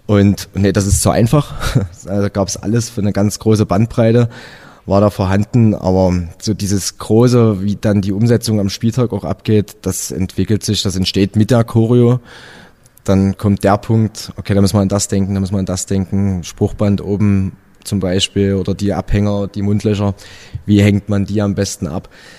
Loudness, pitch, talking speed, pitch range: -15 LUFS, 100 Hz, 195 wpm, 95-110 Hz